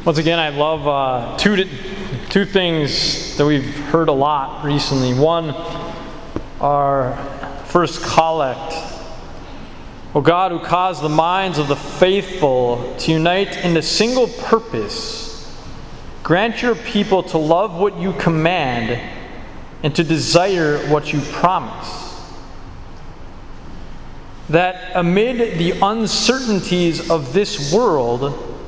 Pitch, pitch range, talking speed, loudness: 165 Hz, 145-185 Hz, 115 wpm, -17 LUFS